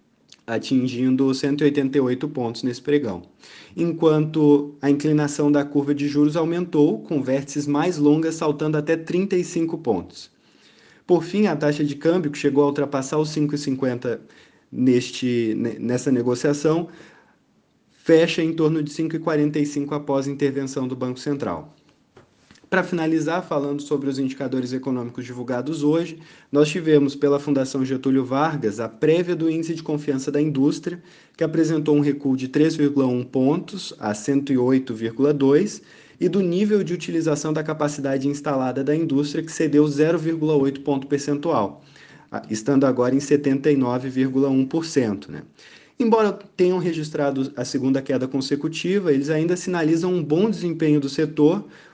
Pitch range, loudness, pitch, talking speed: 135-160 Hz, -22 LUFS, 145 Hz, 135 wpm